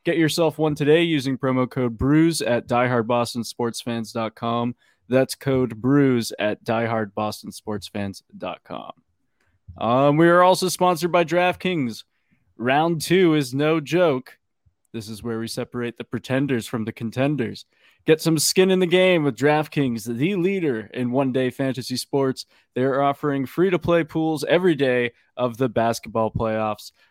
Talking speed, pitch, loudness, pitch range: 135 wpm, 130 Hz, -21 LUFS, 115-155 Hz